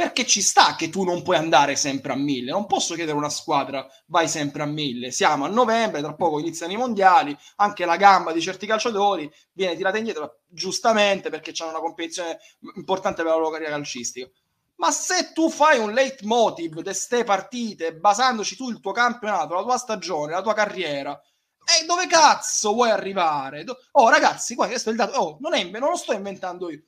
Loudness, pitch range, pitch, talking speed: -21 LUFS, 160-235 Hz, 190 Hz, 195 wpm